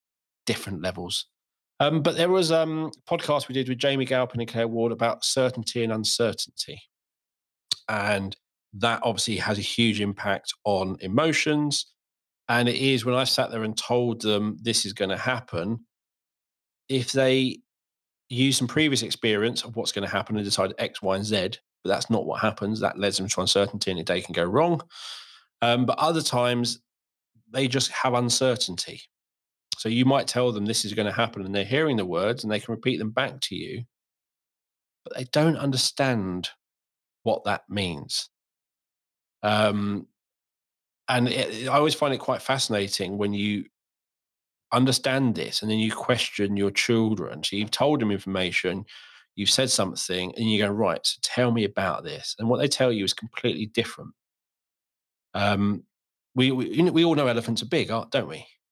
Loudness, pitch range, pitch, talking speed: -25 LUFS, 100-130 Hz, 115 Hz, 180 wpm